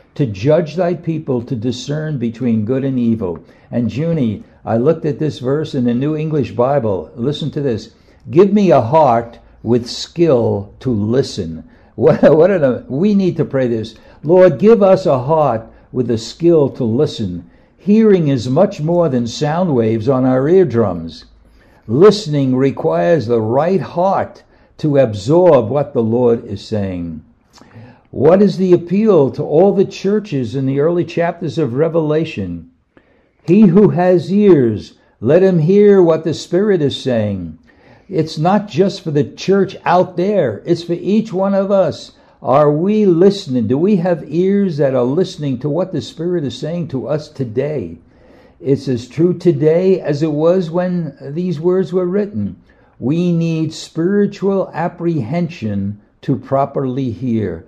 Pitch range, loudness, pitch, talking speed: 120-180 Hz, -15 LUFS, 150 Hz, 160 wpm